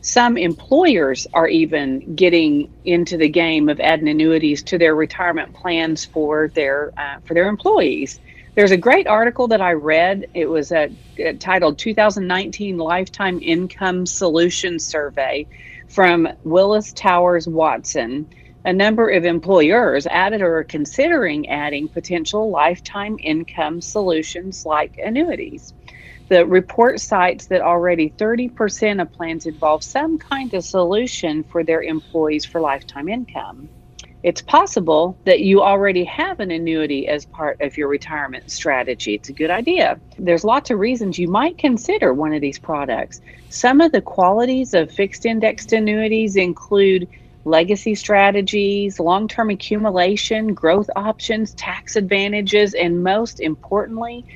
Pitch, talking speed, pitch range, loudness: 180 Hz, 140 wpm, 160-210 Hz, -17 LUFS